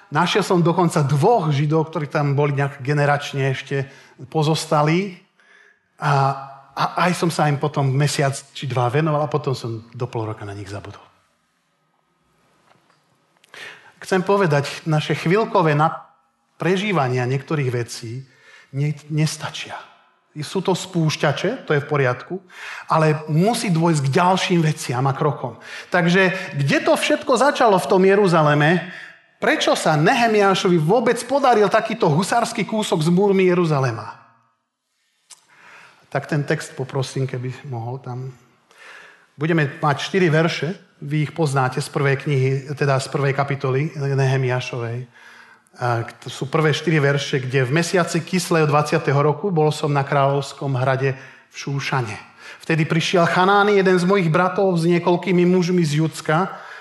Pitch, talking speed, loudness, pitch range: 155 Hz, 135 wpm, -19 LUFS, 135-180 Hz